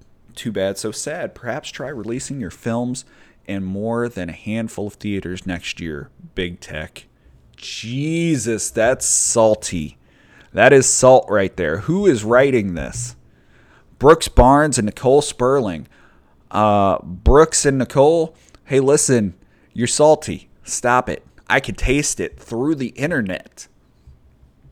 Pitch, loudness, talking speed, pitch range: 105 Hz, -18 LUFS, 130 wpm, 85-130 Hz